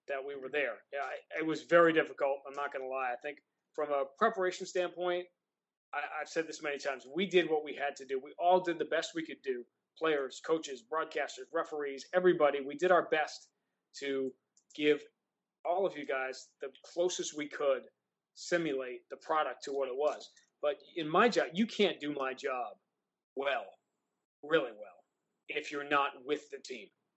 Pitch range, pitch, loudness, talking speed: 140-180 Hz, 155 Hz, -34 LUFS, 190 wpm